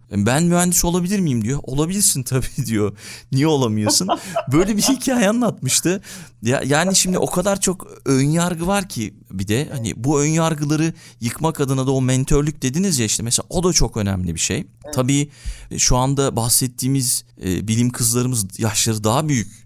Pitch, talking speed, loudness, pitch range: 135 Hz, 160 wpm, -19 LUFS, 115-165 Hz